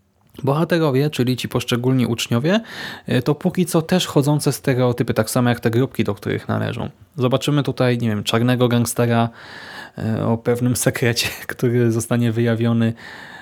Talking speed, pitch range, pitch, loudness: 140 wpm, 115-135 Hz, 125 Hz, -19 LUFS